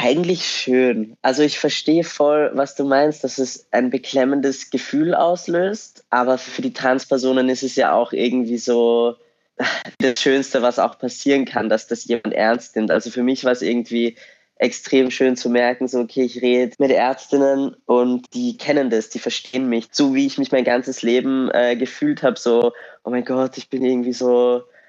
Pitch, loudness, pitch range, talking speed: 130 Hz, -19 LUFS, 120-135 Hz, 185 wpm